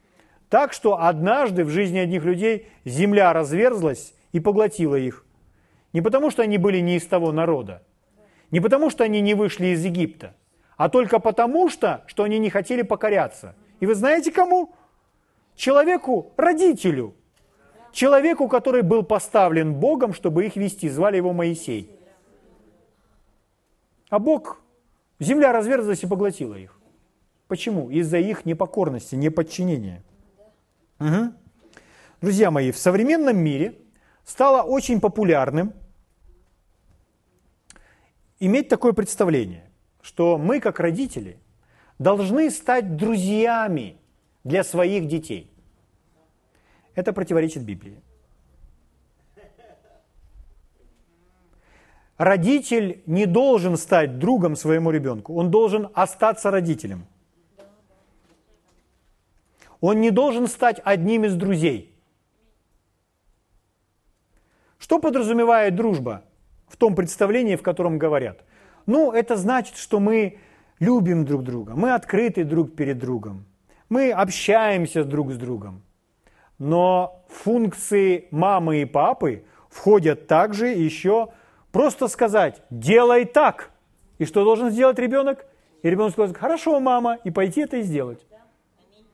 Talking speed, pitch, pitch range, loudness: 110 wpm, 190 Hz, 150-225 Hz, -21 LUFS